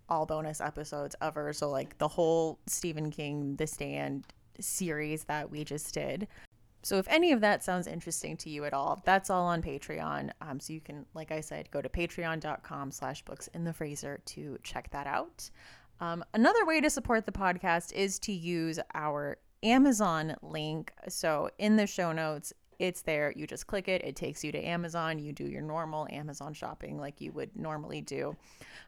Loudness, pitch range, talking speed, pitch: -33 LUFS, 150-180 Hz, 185 wpm, 155 Hz